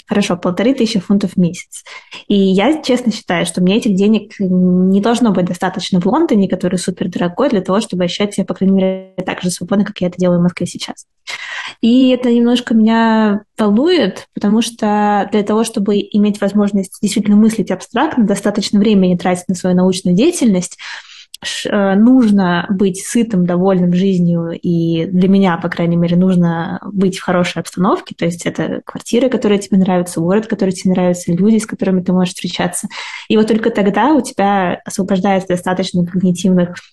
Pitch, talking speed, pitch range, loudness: 195 Hz, 170 wpm, 180-215 Hz, -14 LUFS